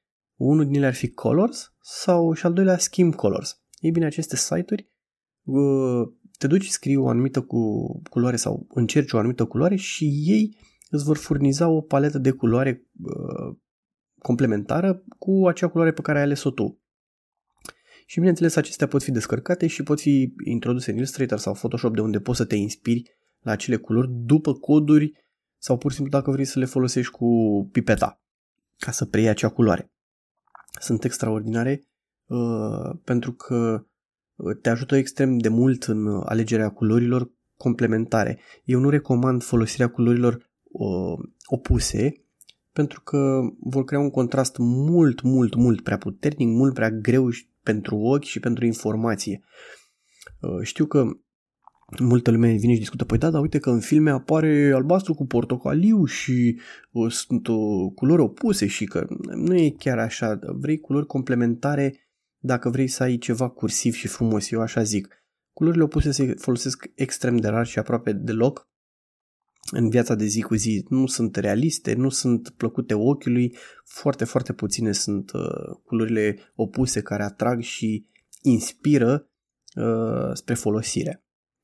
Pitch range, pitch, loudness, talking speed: 115-145 Hz, 125 Hz, -23 LUFS, 150 wpm